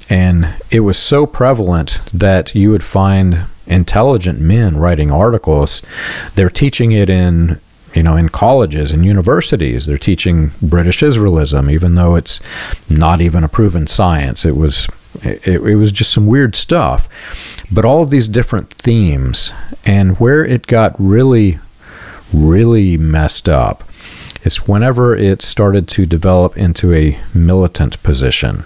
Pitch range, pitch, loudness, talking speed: 80-105 Hz, 90 Hz, -11 LUFS, 145 wpm